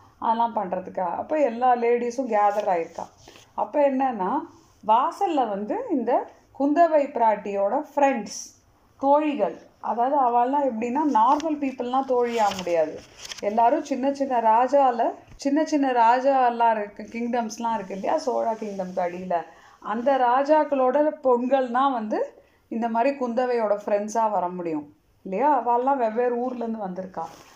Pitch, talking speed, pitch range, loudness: 245 Hz, 115 wpm, 210-275 Hz, -23 LUFS